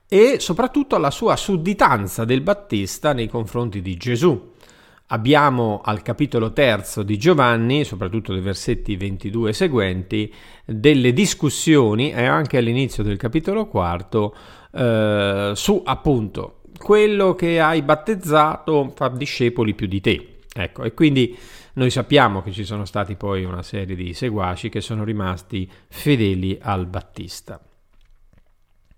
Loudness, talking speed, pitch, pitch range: -19 LUFS, 130 wpm, 115 Hz, 100-145 Hz